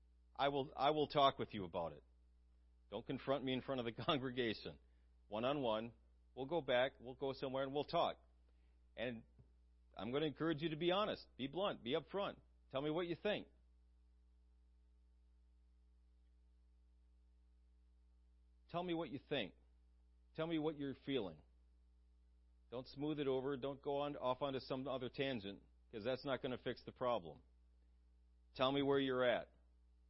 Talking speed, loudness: 165 wpm, -42 LUFS